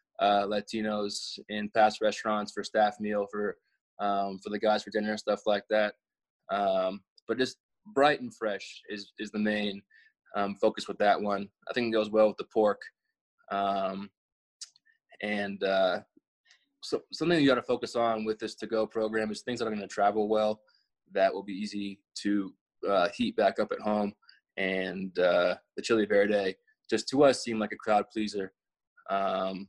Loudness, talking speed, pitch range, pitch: -30 LUFS, 185 wpm, 100-110 Hz, 105 Hz